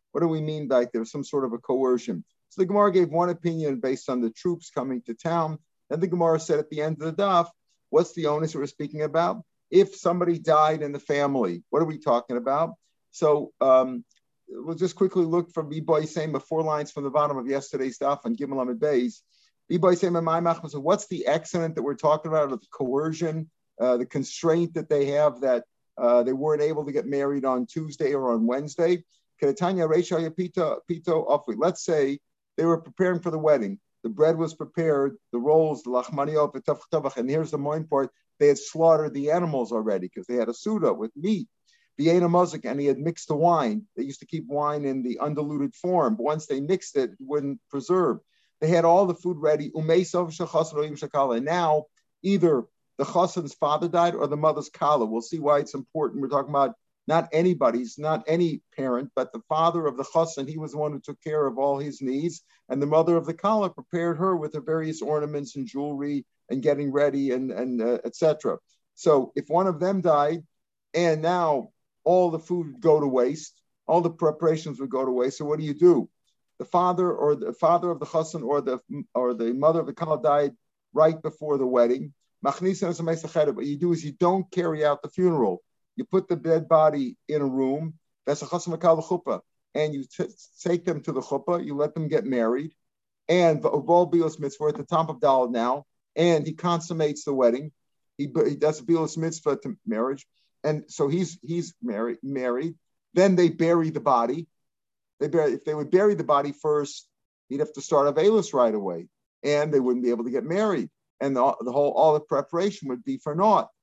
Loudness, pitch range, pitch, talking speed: -25 LUFS, 140-170 Hz, 155 Hz, 200 wpm